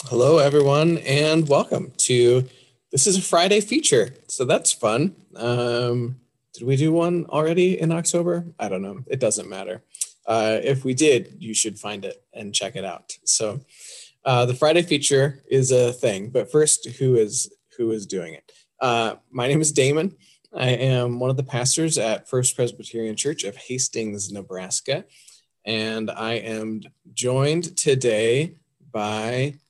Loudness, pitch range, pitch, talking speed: -21 LUFS, 120-155 Hz, 130 Hz, 160 wpm